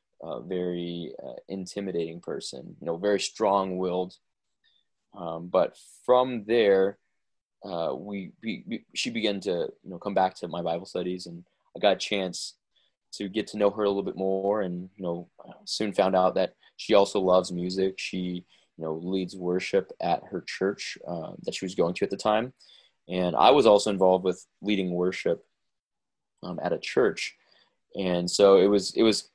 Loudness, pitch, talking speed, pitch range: -27 LUFS, 95 Hz, 180 wpm, 90-100 Hz